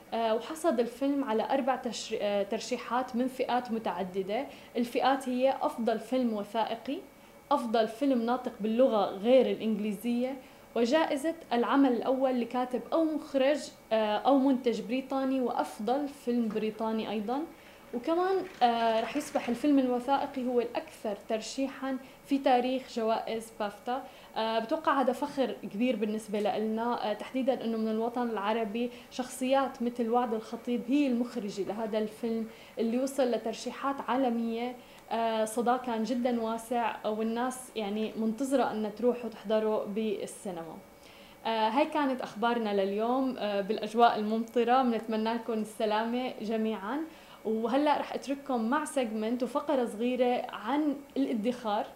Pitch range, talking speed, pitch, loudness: 220-265 Hz, 110 wpm, 240 Hz, -31 LUFS